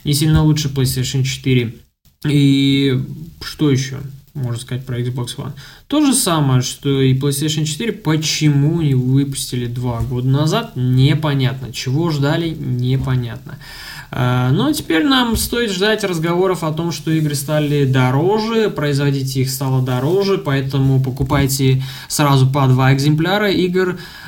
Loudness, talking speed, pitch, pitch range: -16 LUFS, 130 wpm, 140 Hz, 130-155 Hz